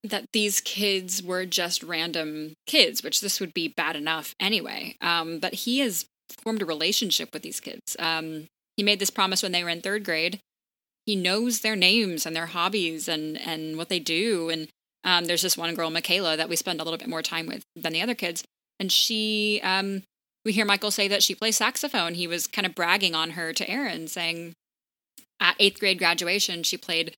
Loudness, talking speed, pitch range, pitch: -25 LUFS, 210 wpm, 165-205 Hz, 180 Hz